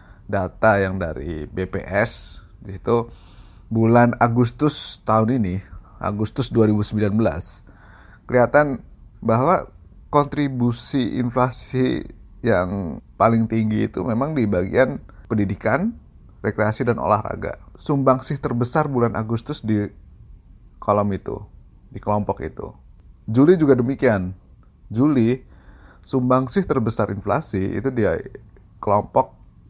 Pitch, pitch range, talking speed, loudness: 110 Hz, 95-125 Hz, 95 wpm, -21 LUFS